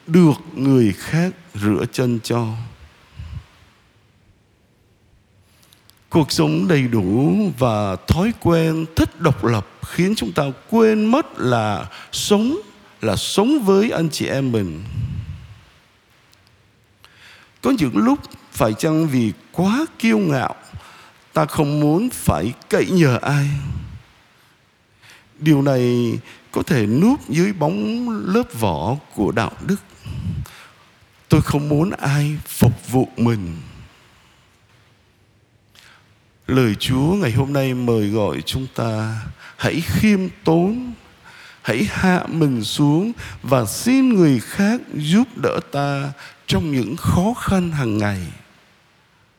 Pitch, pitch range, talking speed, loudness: 130 Hz, 110-170 Hz, 115 wpm, -19 LUFS